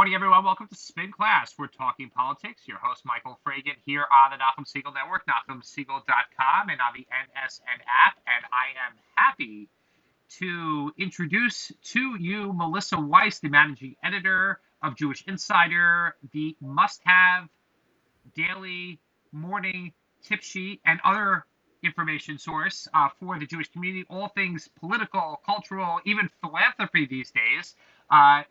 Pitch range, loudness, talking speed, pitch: 145-195 Hz, -24 LUFS, 140 wpm, 175 Hz